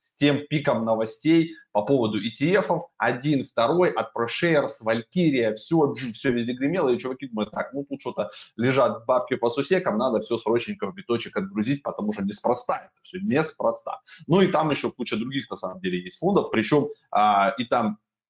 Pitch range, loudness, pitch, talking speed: 110-150 Hz, -24 LUFS, 130 Hz, 175 wpm